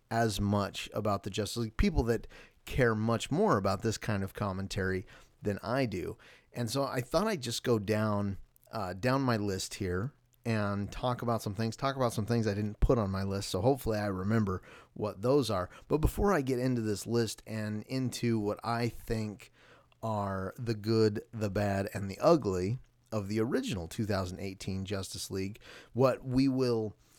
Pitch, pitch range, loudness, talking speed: 110 Hz, 100-120 Hz, -32 LUFS, 185 wpm